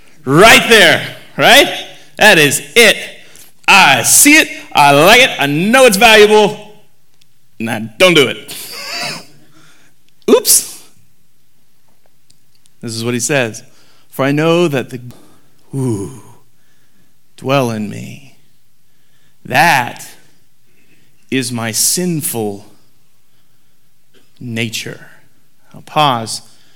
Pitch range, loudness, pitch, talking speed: 115-160 Hz, -9 LUFS, 135 Hz, 95 wpm